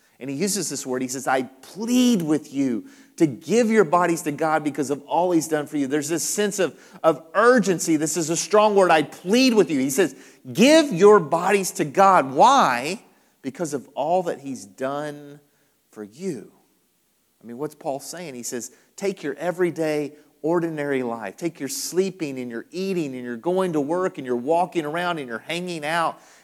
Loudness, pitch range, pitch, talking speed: -22 LUFS, 145-190 Hz, 165 Hz, 195 wpm